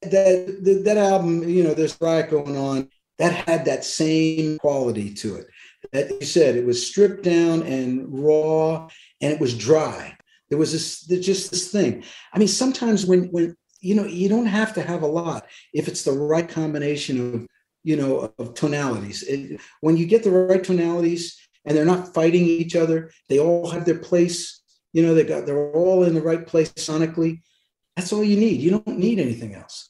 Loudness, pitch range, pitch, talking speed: -21 LUFS, 150-180 Hz, 165 Hz, 200 wpm